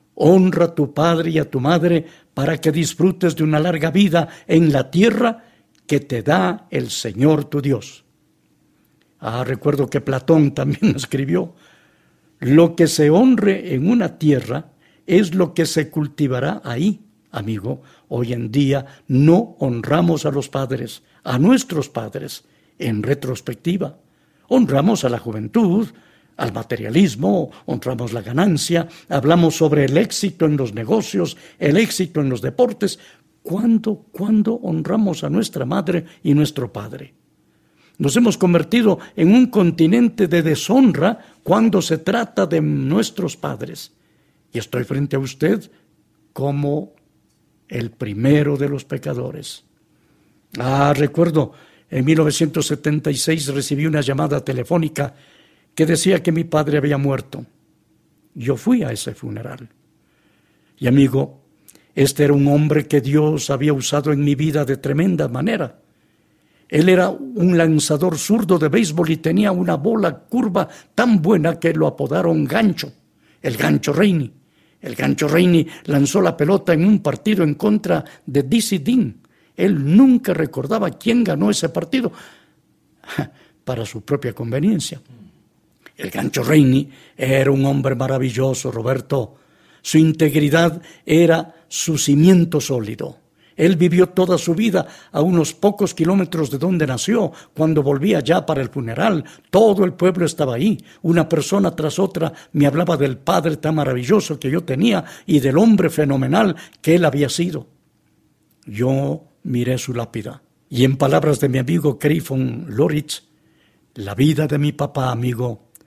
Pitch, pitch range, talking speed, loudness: 155 Hz, 140-180 Hz, 140 wpm, -18 LUFS